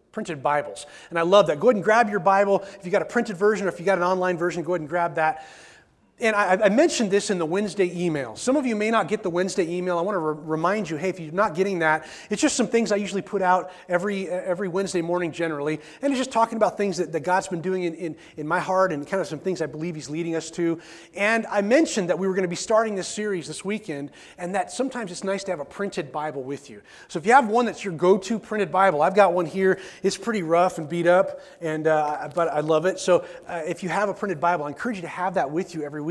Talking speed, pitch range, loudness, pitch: 285 wpm, 170-205 Hz, -23 LUFS, 185 Hz